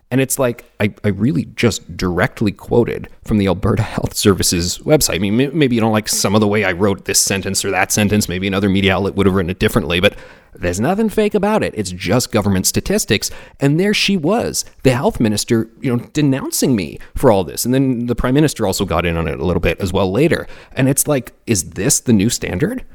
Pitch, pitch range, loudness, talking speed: 110 Hz, 95-130 Hz, -16 LUFS, 235 wpm